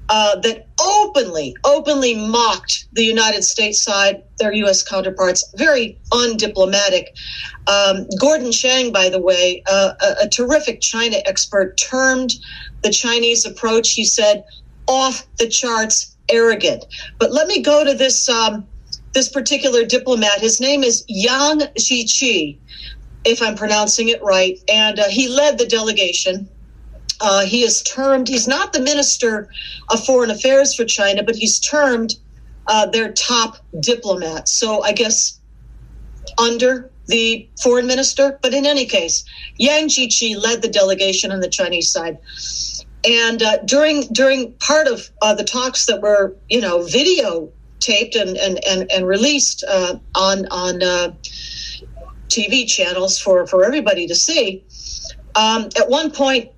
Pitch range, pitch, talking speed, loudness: 200-260 Hz, 230 Hz, 145 wpm, -15 LUFS